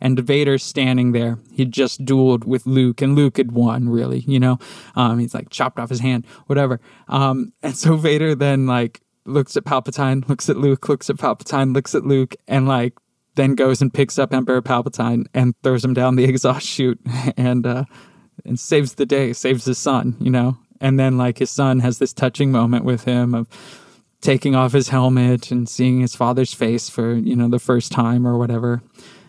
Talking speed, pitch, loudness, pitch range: 200 wpm, 130 Hz, -18 LUFS, 125-135 Hz